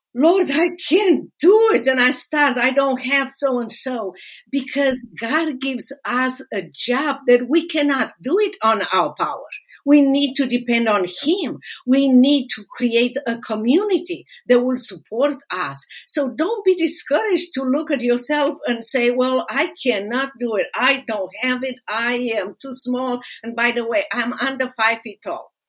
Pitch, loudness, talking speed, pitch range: 260 Hz, -19 LUFS, 180 wpm, 240-290 Hz